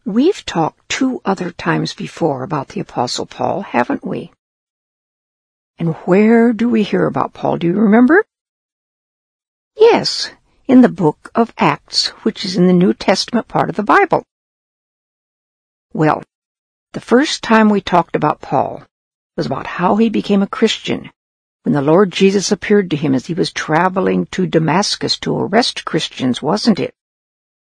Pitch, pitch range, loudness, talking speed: 210 Hz, 180-230 Hz, -15 LUFS, 155 wpm